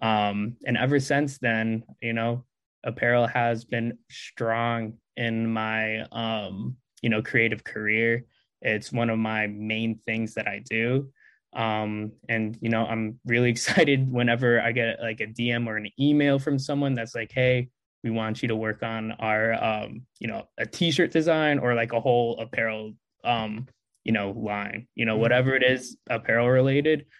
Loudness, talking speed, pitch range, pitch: -25 LUFS, 170 wpm, 110-125 Hz, 115 Hz